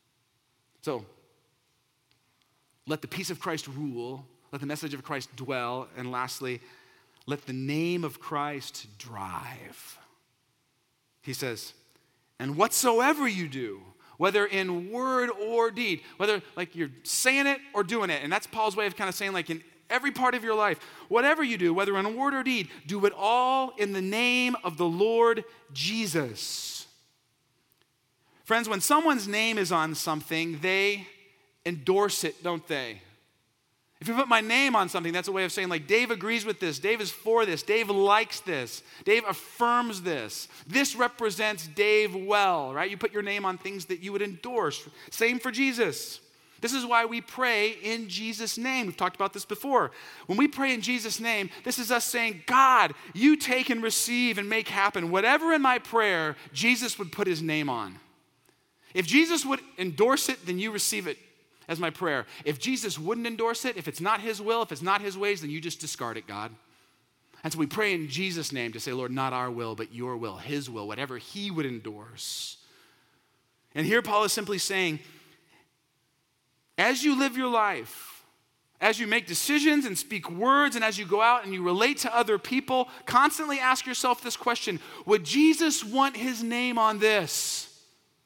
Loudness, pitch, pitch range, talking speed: -27 LUFS, 200 Hz, 150-235 Hz, 180 wpm